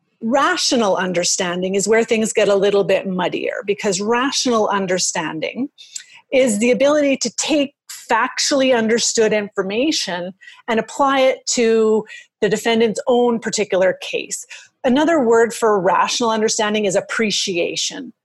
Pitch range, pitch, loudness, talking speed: 205-270 Hz, 230 Hz, -17 LUFS, 120 wpm